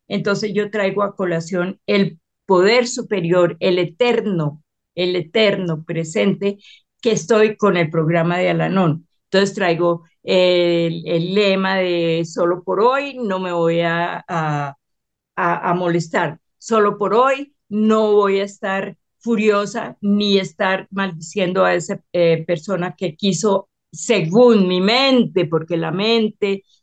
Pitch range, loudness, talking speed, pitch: 175-210 Hz, -18 LUFS, 135 wpm, 190 Hz